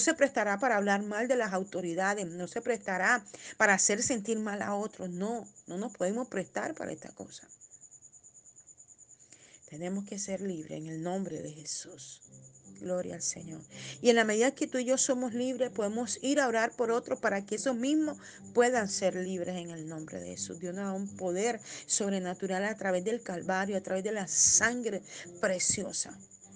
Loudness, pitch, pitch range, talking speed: -31 LUFS, 200 Hz, 180-235 Hz, 185 wpm